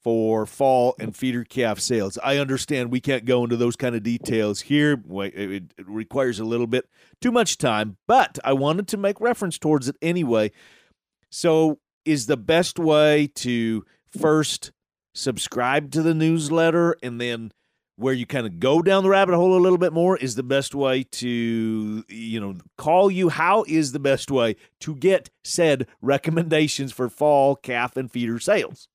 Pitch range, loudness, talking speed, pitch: 115-160 Hz, -22 LUFS, 175 wpm, 135 Hz